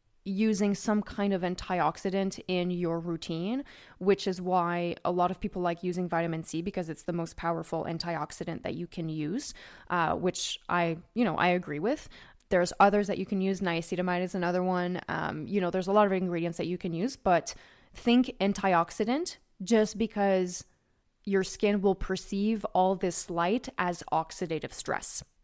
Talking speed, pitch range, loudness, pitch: 175 wpm, 175-200 Hz, -30 LUFS, 185 Hz